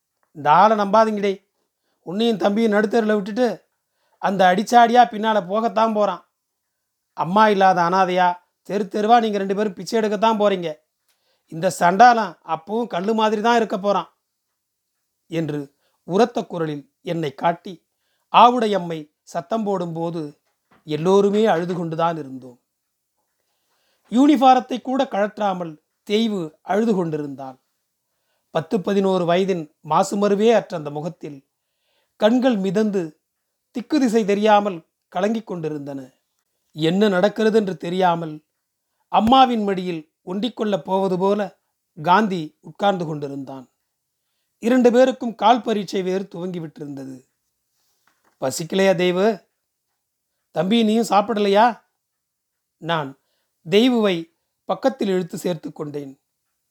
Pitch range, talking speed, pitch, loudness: 165-220 Hz, 100 wpm, 195 Hz, -19 LUFS